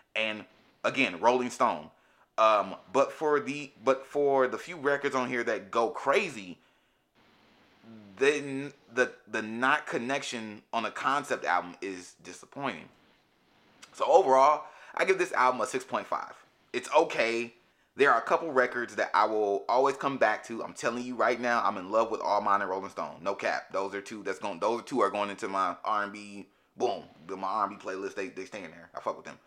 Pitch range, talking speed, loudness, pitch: 105-140 Hz, 185 wpm, -29 LUFS, 125 Hz